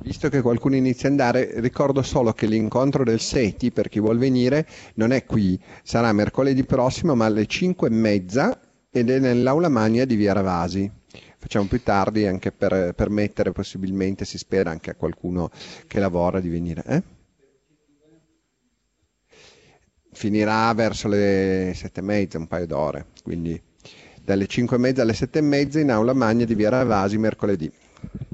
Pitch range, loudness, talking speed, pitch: 95-130 Hz, -22 LUFS, 160 wpm, 110 Hz